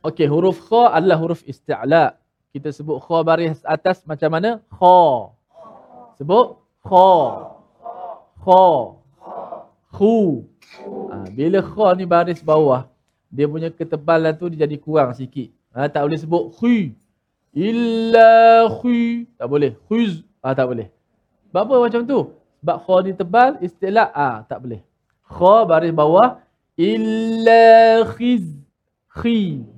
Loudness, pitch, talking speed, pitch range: -16 LUFS, 170 Hz, 125 wpm, 150-225 Hz